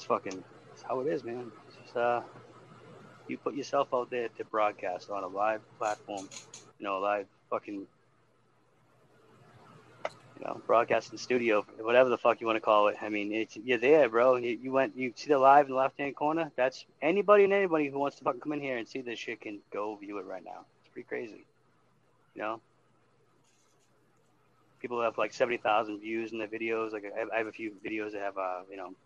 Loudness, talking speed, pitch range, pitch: -30 LUFS, 205 wpm, 105-130 Hz, 115 Hz